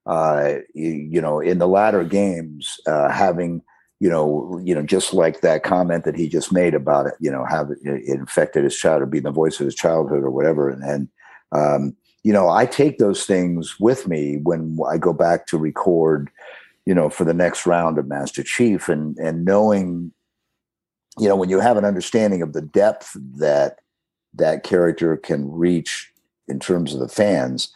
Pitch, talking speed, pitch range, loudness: 80 Hz, 195 wpm, 75-90 Hz, -19 LUFS